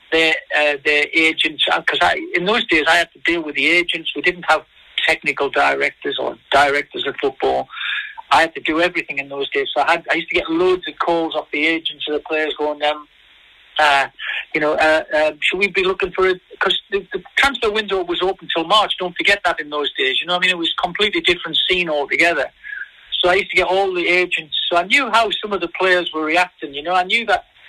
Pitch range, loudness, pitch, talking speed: 155-200 Hz, -17 LUFS, 175 Hz, 245 wpm